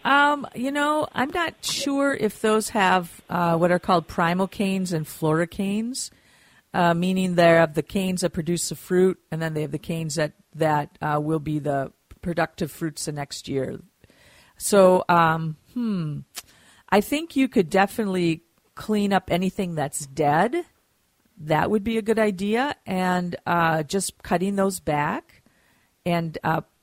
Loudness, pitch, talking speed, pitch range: -23 LUFS, 180 Hz, 160 wpm, 160-210 Hz